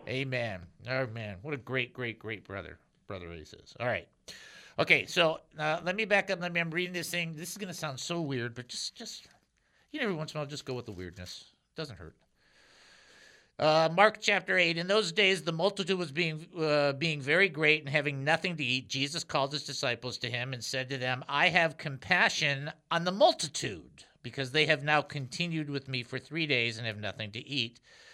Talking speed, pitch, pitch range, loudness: 220 wpm, 150 Hz, 125-170 Hz, -30 LUFS